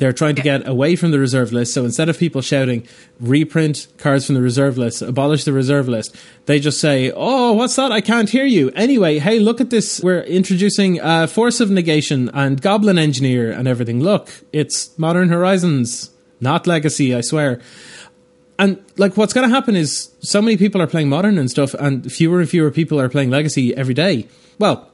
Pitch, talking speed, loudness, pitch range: 150 Hz, 200 wpm, -16 LUFS, 135-190 Hz